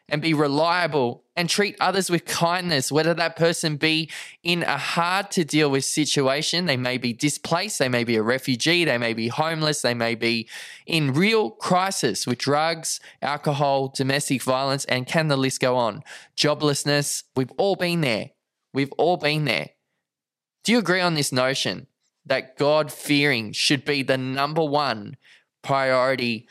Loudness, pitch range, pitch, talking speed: -22 LUFS, 130-165 Hz, 145 Hz, 165 wpm